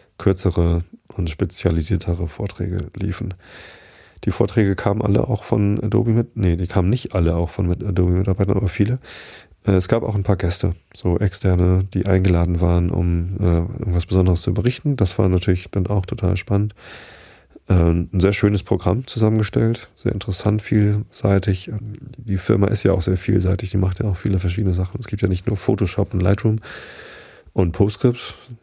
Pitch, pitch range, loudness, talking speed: 95 Hz, 90-105 Hz, -20 LUFS, 165 wpm